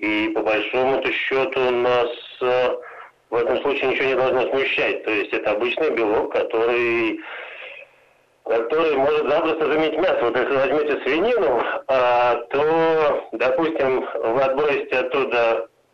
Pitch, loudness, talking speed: 135 Hz, -20 LUFS, 135 wpm